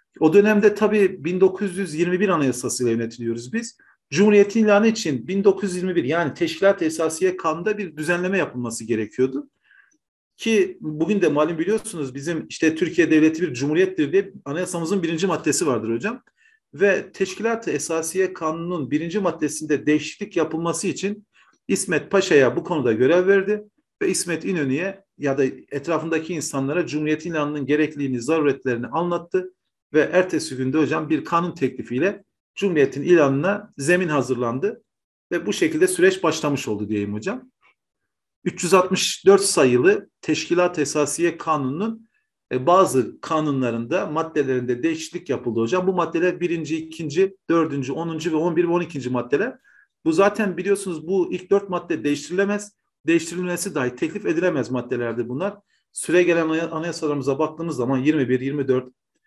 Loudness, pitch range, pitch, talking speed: -21 LUFS, 145-195 Hz, 165 Hz, 130 wpm